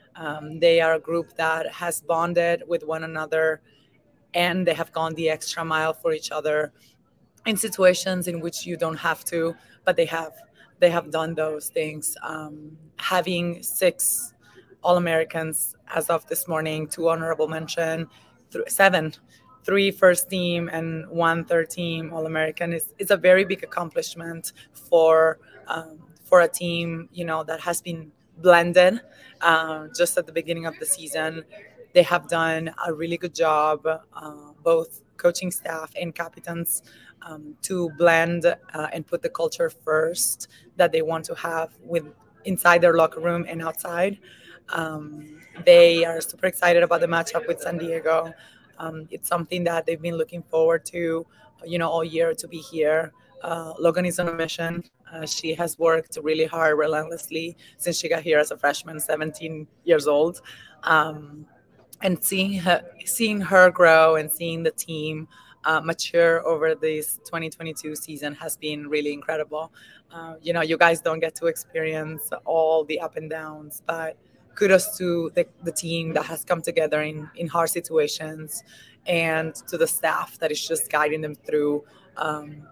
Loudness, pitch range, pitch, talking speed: -23 LUFS, 155-170 Hz, 165 Hz, 165 wpm